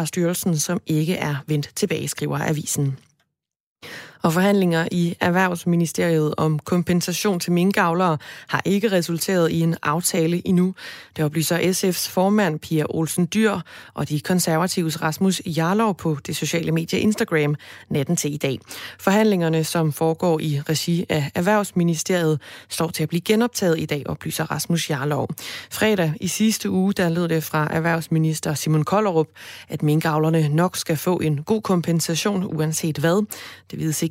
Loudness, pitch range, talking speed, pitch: -21 LUFS, 155-185 Hz, 150 wpm, 165 Hz